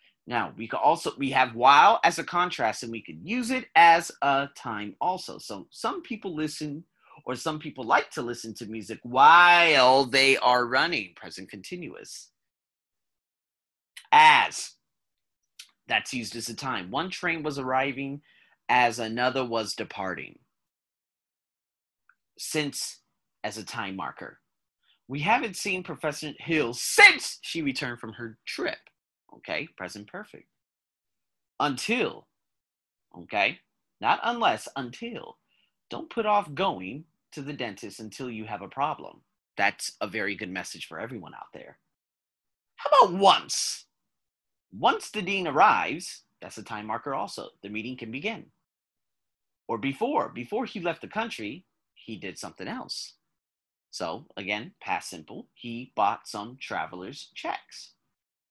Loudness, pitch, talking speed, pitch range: -25 LUFS, 135 Hz, 135 wpm, 115-175 Hz